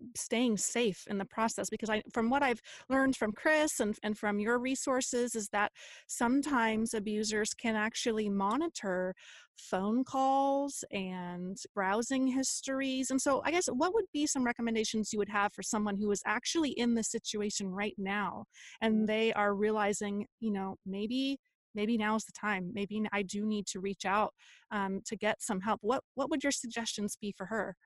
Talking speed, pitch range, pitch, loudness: 180 wpm, 205-255 Hz, 220 Hz, -33 LUFS